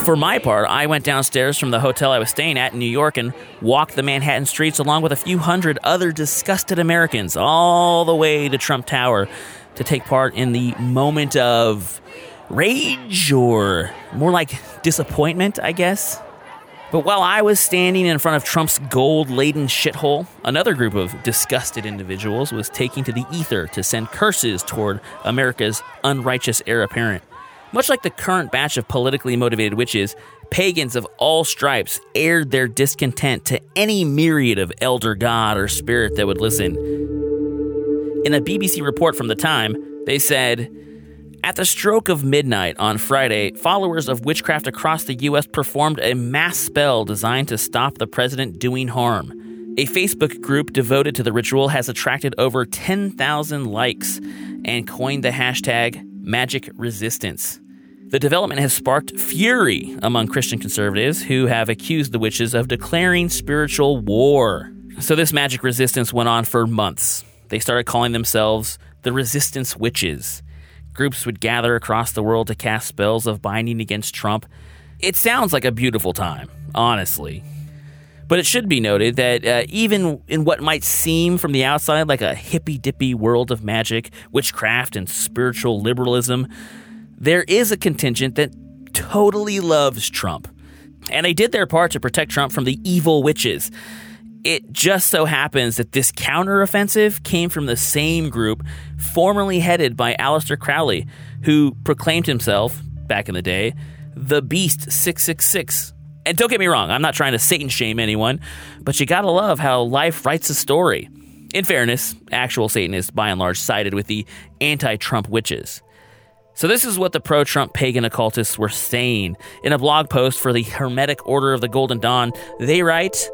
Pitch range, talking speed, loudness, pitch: 115-155 Hz, 165 wpm, -18 LUFS, 135 Hz